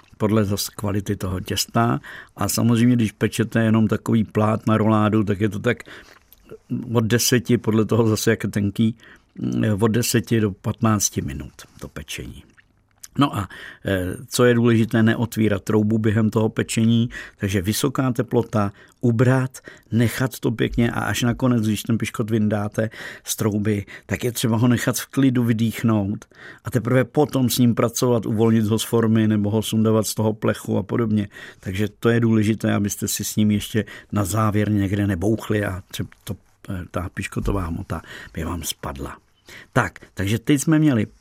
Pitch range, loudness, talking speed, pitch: 105-120 Hz, -21 LUFS, 165 wpm, 110 Hz